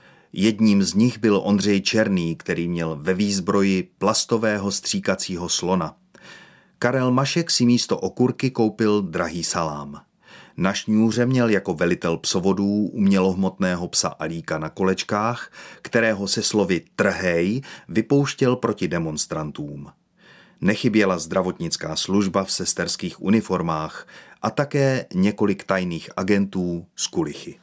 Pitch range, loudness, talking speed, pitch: 90-115 Hz, -22 LUFS, 115 wpm, 100 Hz